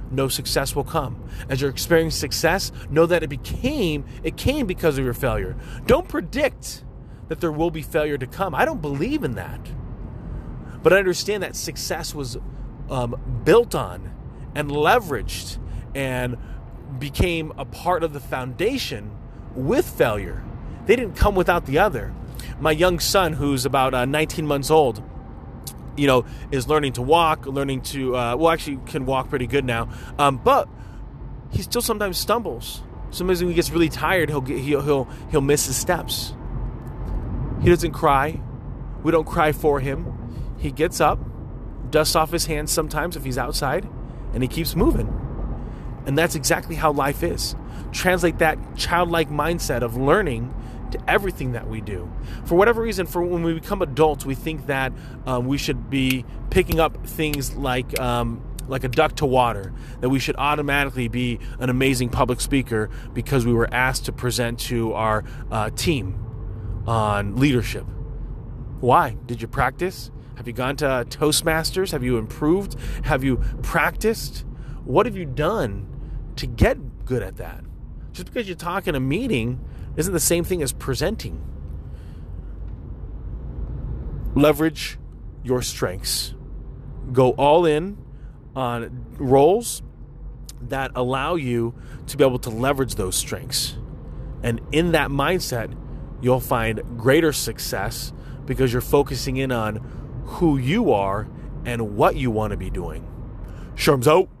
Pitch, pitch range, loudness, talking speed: 130 Hz, 120-155 Hz, -22 LUFS, 155 wpm